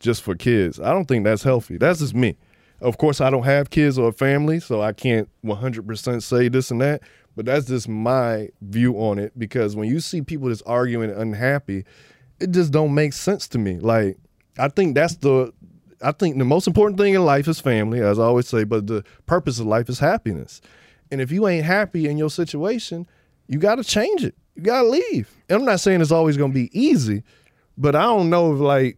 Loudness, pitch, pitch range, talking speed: -20 LUFS, 130 Hz, 115-160 Hz, 230 wpm